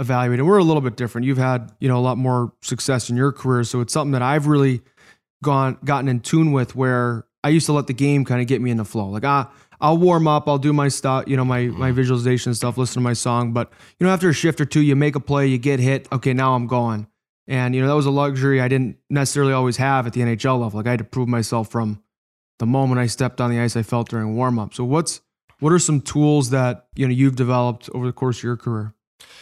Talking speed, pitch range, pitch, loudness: 270 wpm, 120-140 Hz, 130 Hz, -20 LUFS